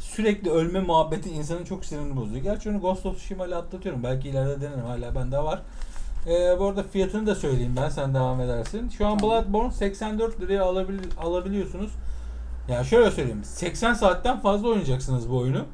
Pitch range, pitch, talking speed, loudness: 135-200 Hz, 180 Hz, 180 wpm, -26 LUFS